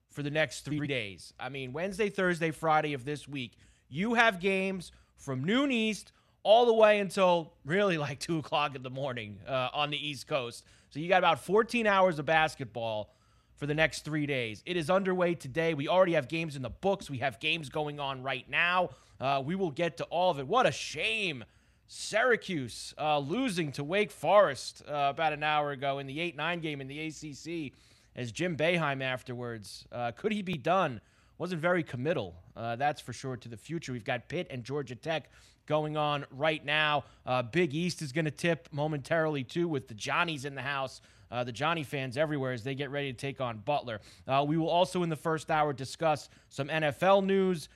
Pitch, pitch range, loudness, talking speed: 150 Hz, 130-170 Hz, -31 LUFS, 205 wpm